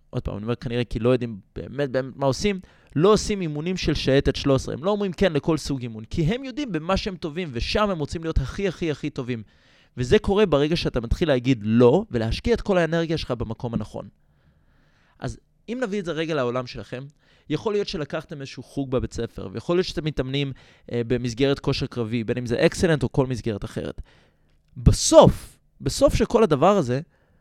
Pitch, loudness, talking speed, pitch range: 140 Hz, -23 LUFS, 195 wpm, 125-175 Hz